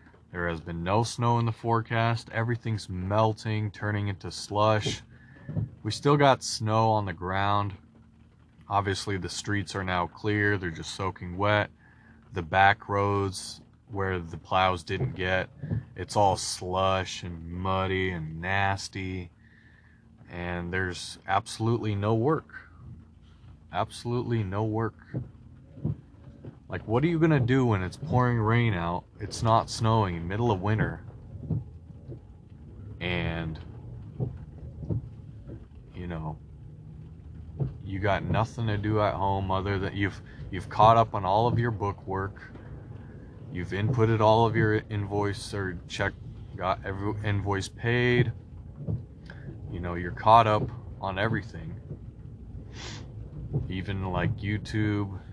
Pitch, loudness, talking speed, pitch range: 105 Hz, -28 LUFS, 125 wpm, 95-115 Hz